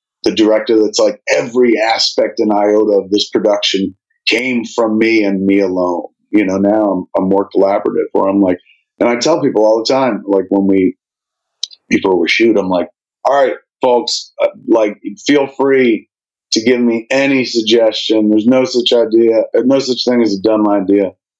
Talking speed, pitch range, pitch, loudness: 180 wpm, 100-120 Hz, 110 Hz, -13 LUFS